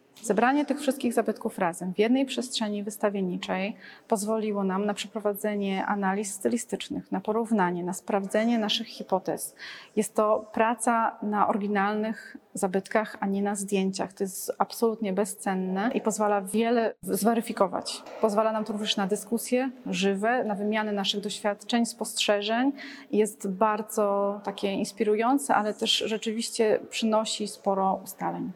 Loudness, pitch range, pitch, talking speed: -27 LUFS, 200-225 Hz, 215 Hz, 130 wpm